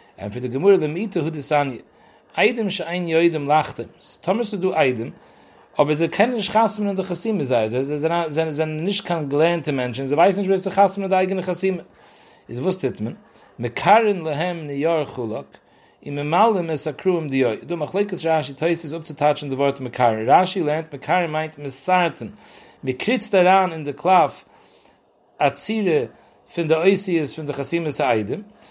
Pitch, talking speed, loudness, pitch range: 165 Hz, 180 wpm, -21 LUFS, 145-190 Hz